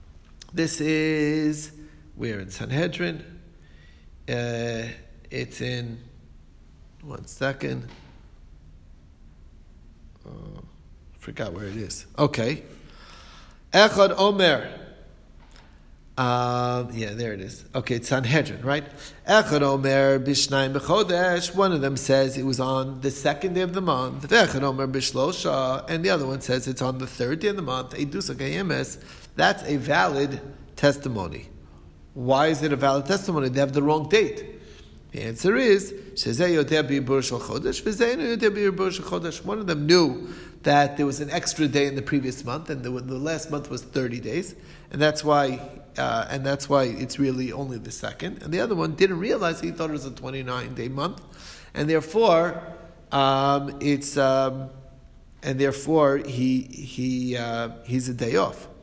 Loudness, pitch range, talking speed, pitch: -24 LUFS, 120-155 Hz, 140 wpm, 135 Hz